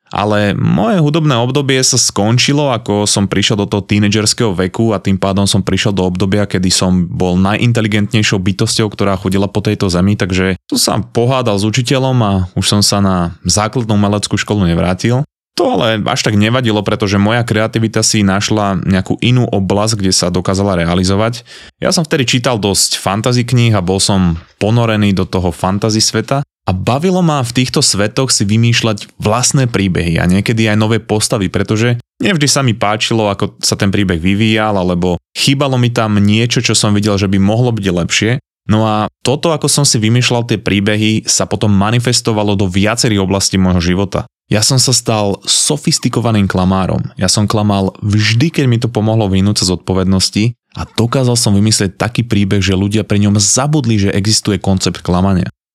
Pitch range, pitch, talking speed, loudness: 95-120 Hz, 105 Hz, 180 wpm, -12 LUFS